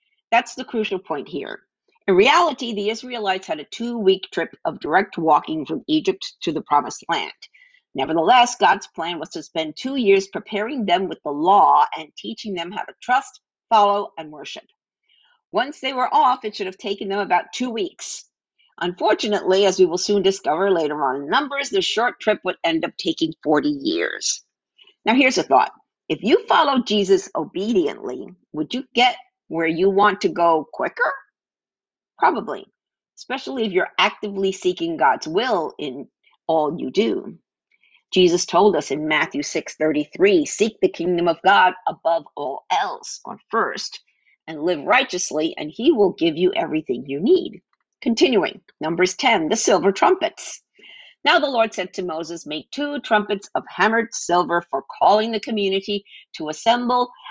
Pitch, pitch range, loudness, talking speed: 215 Hz, 180-300 Hz, -20 LUFS, 165 wpm